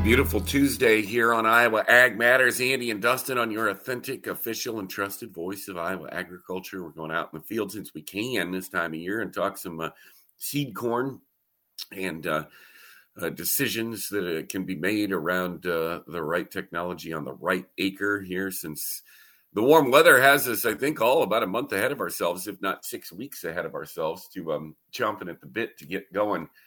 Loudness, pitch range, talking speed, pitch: -25 LUFS, 90-120 Hz, 200 wpm, 100 Hz